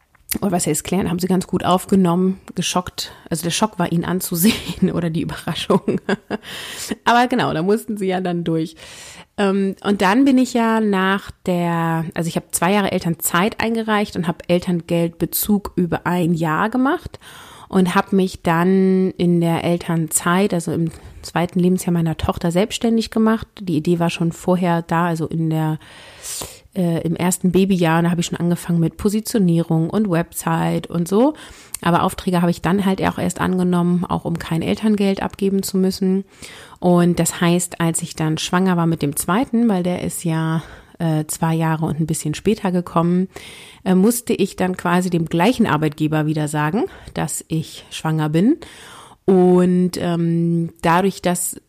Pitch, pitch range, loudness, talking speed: 175 Hz, 165-195 Hz, -19 LUFS, 165 wpm